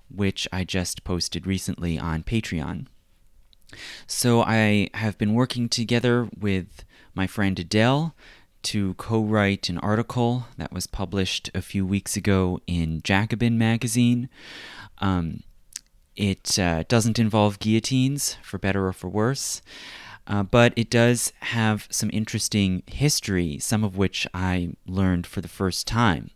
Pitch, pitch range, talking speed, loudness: 100 Hz, 95-115 Hz, 135 wpm, -24 LUFS